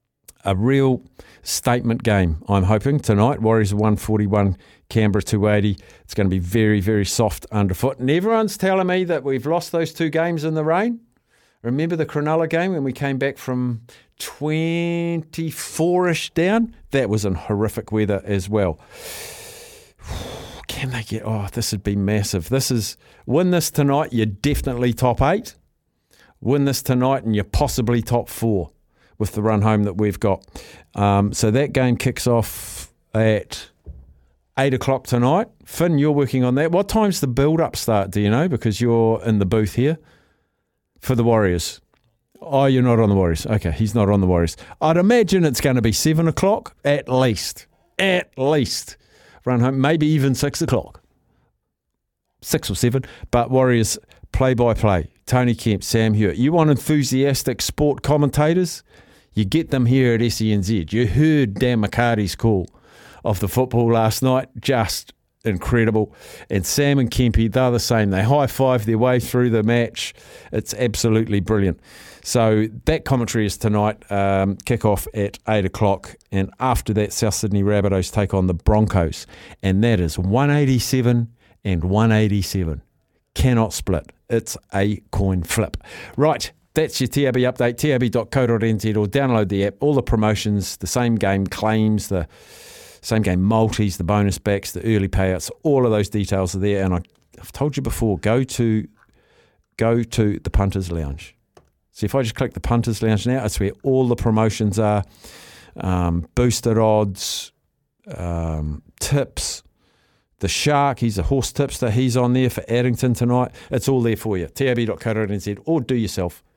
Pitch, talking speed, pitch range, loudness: 115 Hz, 165 wpm, 100-135 Hz, -20 LUFS